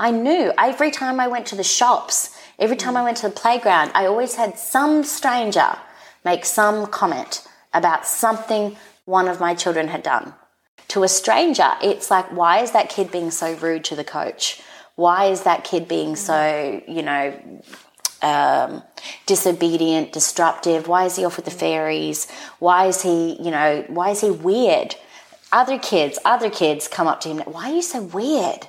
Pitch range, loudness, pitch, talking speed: 165-230 Hz, -19 LUFS, 185 Hz, 180 wpm